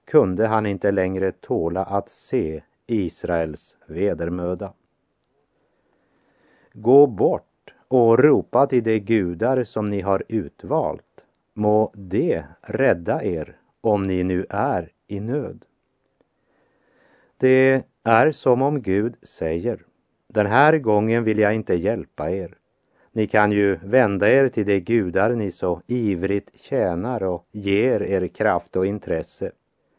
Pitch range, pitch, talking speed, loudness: 95-115 Hz, 105 Hz, 125 wpm, -21 LUFS